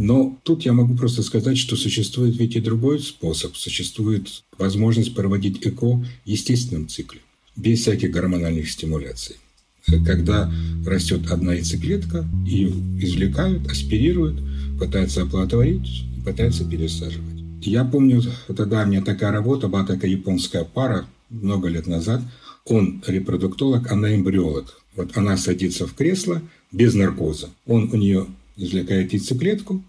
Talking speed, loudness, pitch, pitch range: 130 wpm, -21 LUFS, 95 Hz, 85-115 Hz